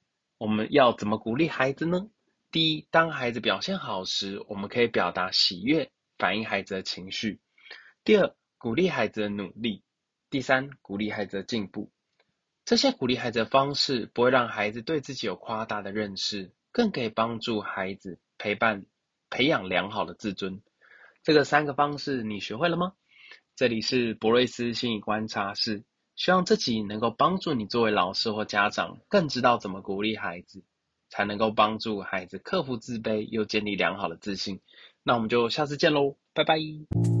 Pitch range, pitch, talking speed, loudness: 105-145 Hz, 115 Hz, 270 characters per minute, -27 LUFS